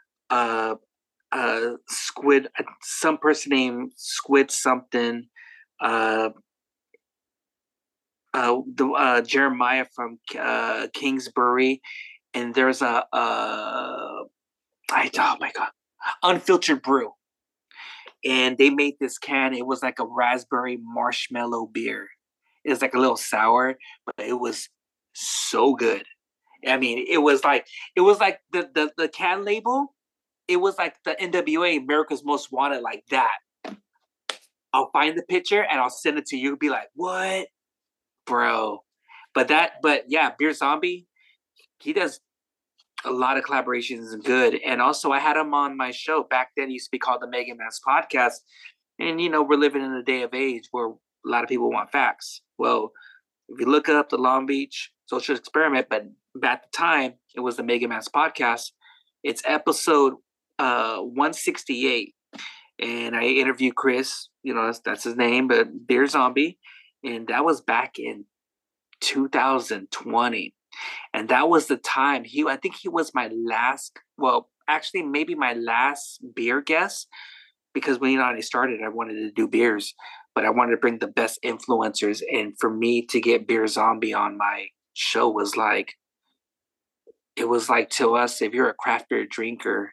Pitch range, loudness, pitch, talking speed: 125-175 Hz, -23 LUFS, 135 Hz, 160 wpm